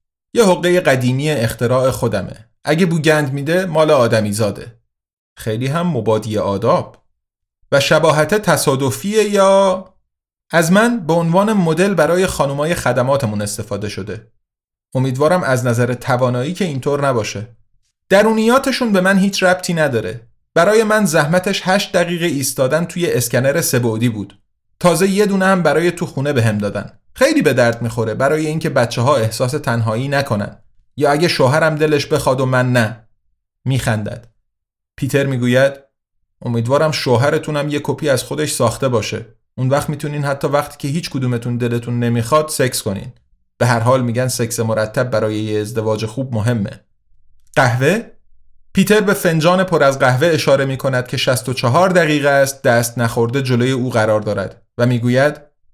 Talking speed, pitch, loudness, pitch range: 145 wpm, 135 Hz, -16 LUFS, 115-160 Hz